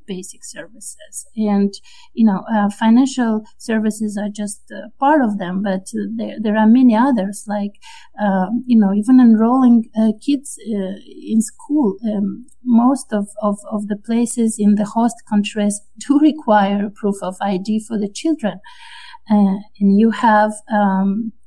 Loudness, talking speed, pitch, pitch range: -17 LUFS, 155 wpm, 215 Hz, 205-240 Hz